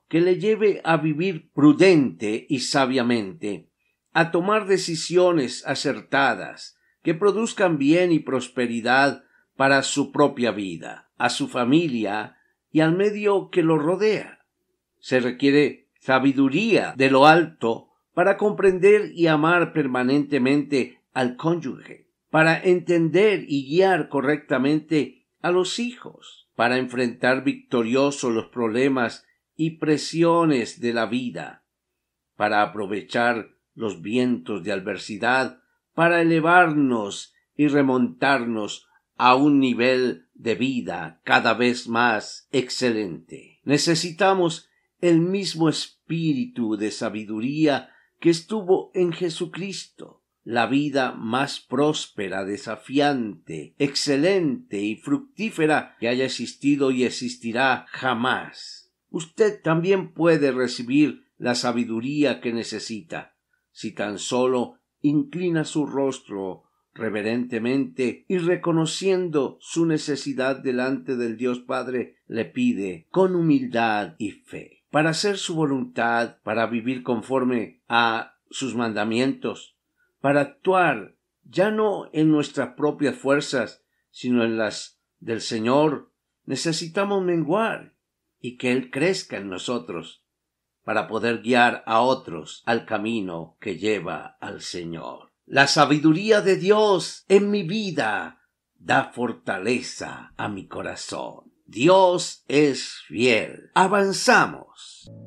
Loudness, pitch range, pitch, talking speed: -22 LUFS, 120-170 Hz, 140 Hz, 110 wpm